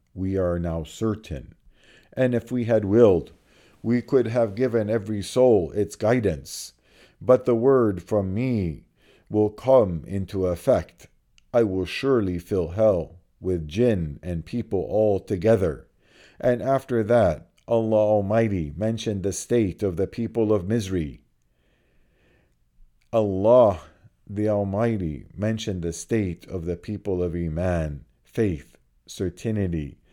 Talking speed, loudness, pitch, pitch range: 125 wpm, -24 LUFS, 100 Hz, 85-115 Hz